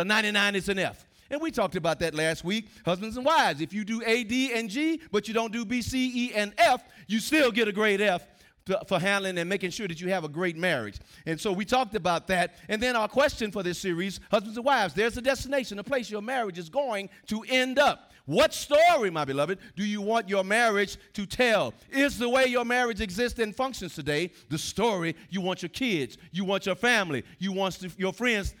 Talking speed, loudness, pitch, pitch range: 230 wpm, -27 LUFS, 210 Hz, 185-245 Hz